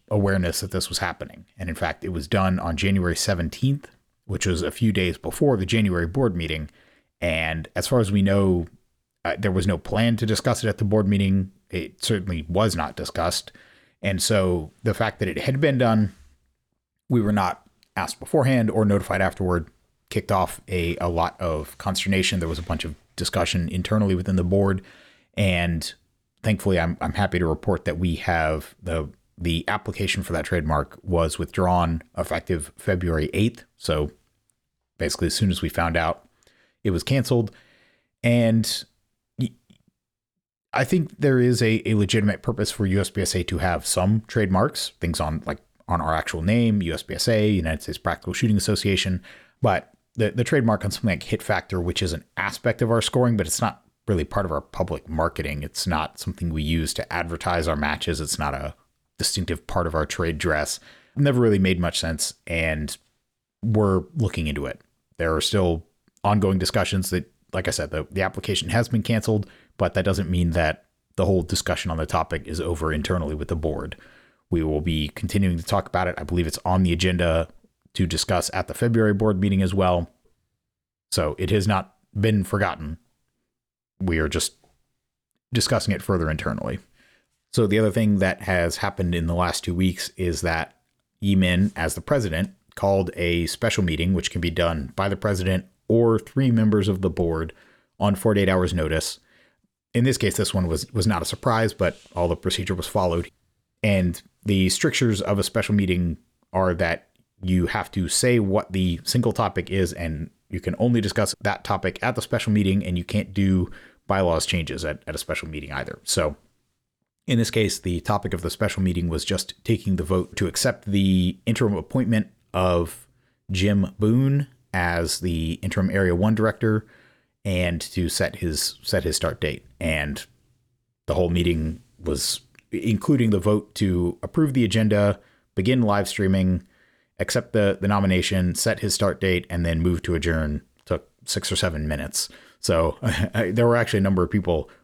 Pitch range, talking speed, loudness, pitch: 85-105 Hz, 180 wpm, -24 LUFS, 95 Hz